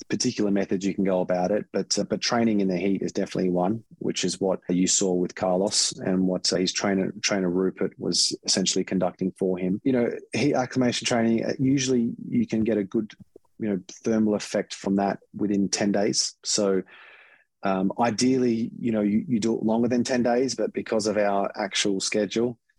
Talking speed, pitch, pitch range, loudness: 200 wpm, 105 Hz, 95-115 Hz, -25 LUFS